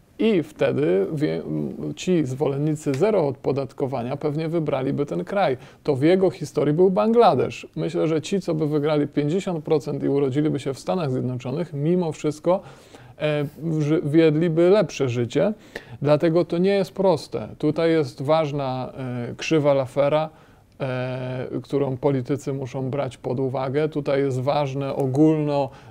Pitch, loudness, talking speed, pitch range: 145 Hz, -23 LUFS, 125 wpm, 135-160 Hz